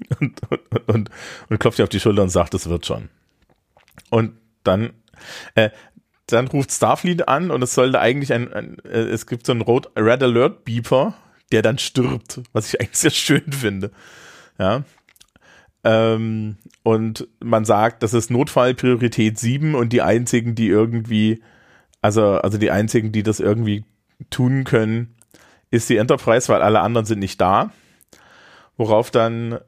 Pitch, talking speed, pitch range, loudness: 115 Hz, 160 wpm, 110-125 Hz, -19 LUFS